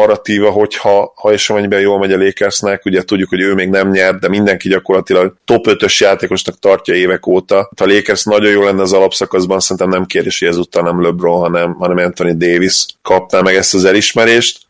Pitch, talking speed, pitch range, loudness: 95 Hz, 190 wpm, 90-100 Hz, -11 LUFS